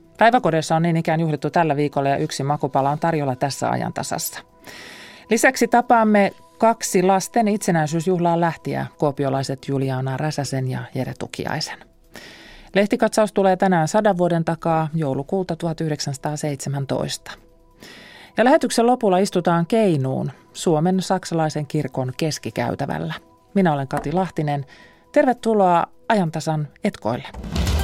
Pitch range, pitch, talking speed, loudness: 145-195 Hz, 165 Hz, 110 wpm, -21 LUFS